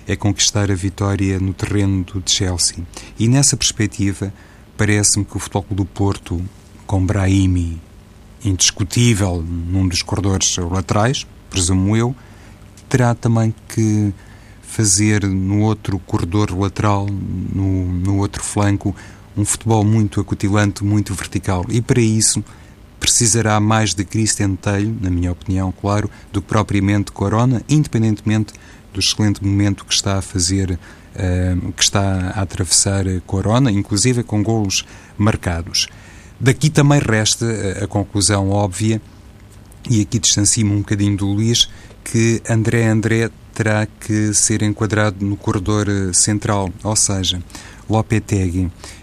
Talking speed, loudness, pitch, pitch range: 125 wpm, -17 LUFS, 100 Hz, 95-110 Hz